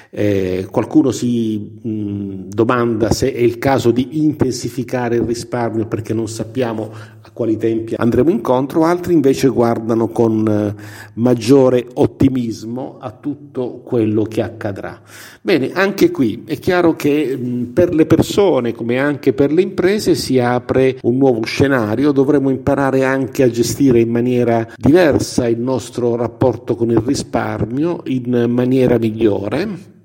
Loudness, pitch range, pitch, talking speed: -16 LUFS, 115-135 Hz, 120 Hz, 140 wpm